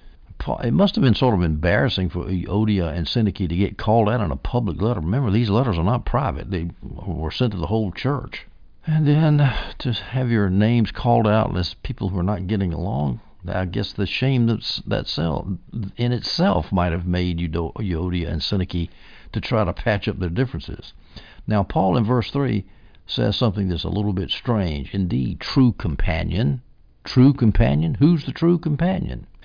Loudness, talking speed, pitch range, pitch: -21 LUFS, 180 wpm, 90-120 Hz, 105 Hz